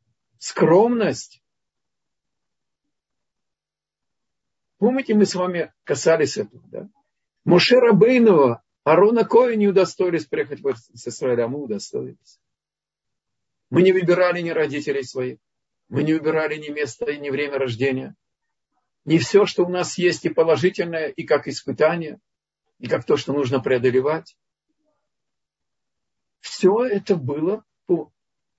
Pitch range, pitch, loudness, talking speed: 140-200 Hz, 165 Hz, -20 LUFS, 115 wpm